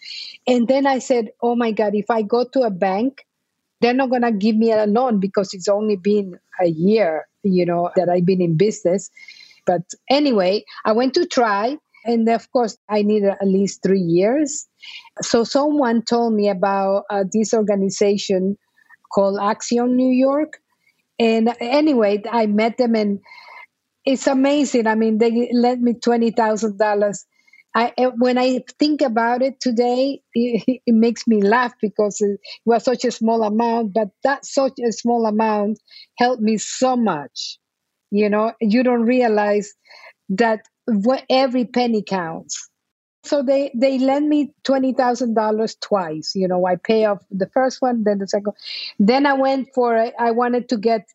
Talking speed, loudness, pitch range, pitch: 165 wpm, -19 LUFS, 210-255 Hz, 230 Hz